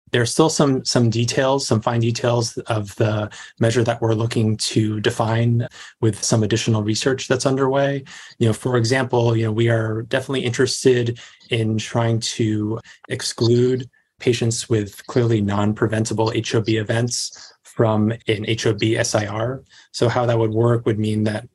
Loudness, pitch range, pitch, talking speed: -20 LUFS, 110-125 Hz, 115 Hz, 155 wpm